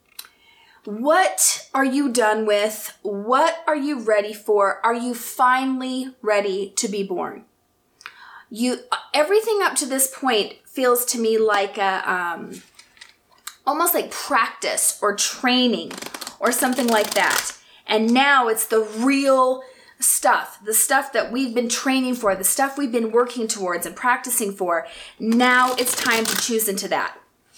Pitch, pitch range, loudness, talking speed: 245 Hz, 215-265 Hz, -20 LUFS, 145 wpm